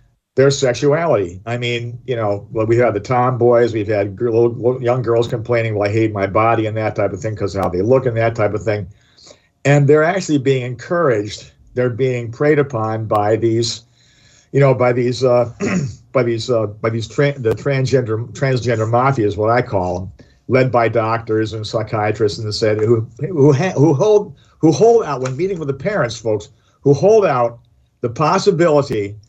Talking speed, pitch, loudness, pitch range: 200 wpm, 120 Hz, -16 LUFS, 110-135 Hz